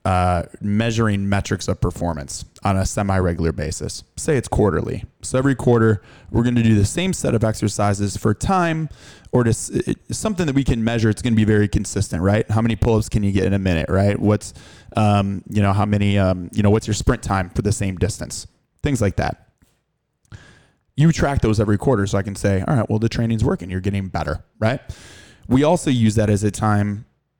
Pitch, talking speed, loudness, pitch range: 105 Hz, 210 wpm, -20 LUFS, 100-115 Hz